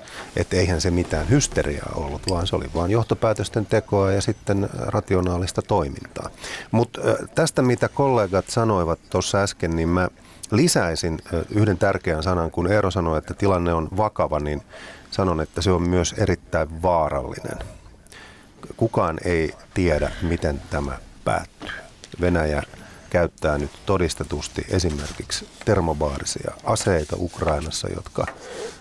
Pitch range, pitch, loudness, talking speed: 80-105 Hz, 90 Hz, -23 LUFS, 125 wpm